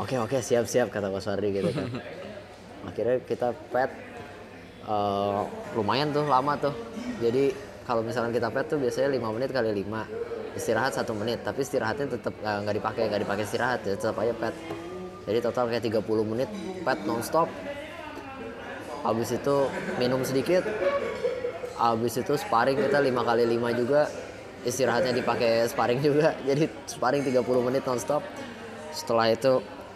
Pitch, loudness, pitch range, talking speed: 125 Hz, -27 LUFS, 110-145 Hz, 150 wpm